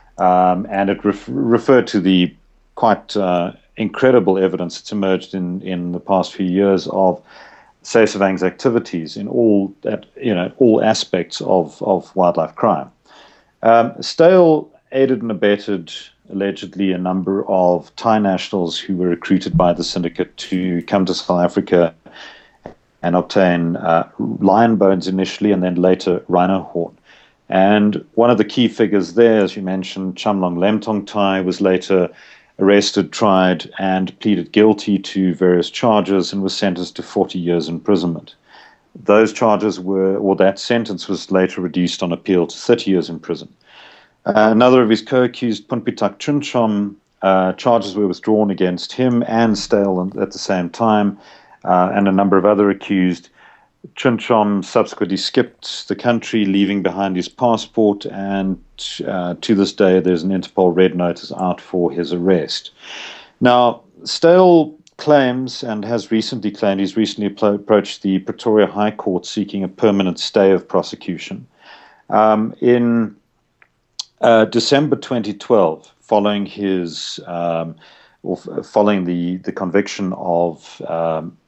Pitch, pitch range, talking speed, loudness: 100 Hz, 90-110 Hz, 145 wpm, -17 LUFS